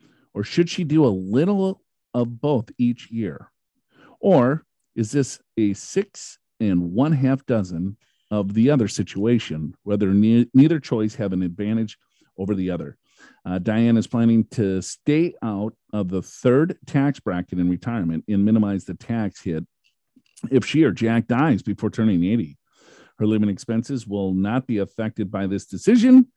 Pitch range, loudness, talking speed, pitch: 100-130 Hz, -22 LUFS, 160 wpm, 110 Hz